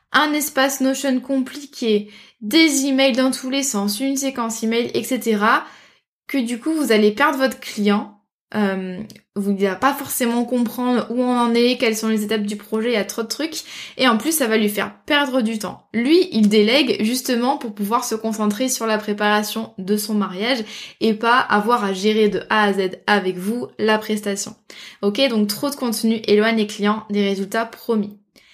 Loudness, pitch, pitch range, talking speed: -19 LUFS, 225 Hz, 210-260 Hz, 195 wpm